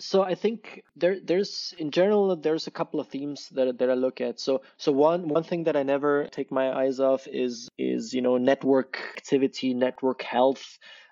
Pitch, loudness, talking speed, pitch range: 140 Hz, -26 LUFS, 200 wpm, 130-170 Hz